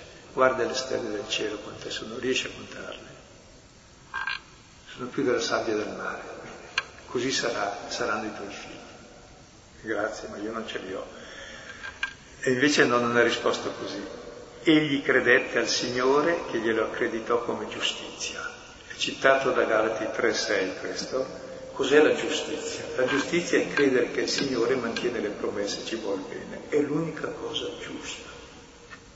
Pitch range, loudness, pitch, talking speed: 130-160 Hz, -27 LUFS, 140 Hz, 145 wpm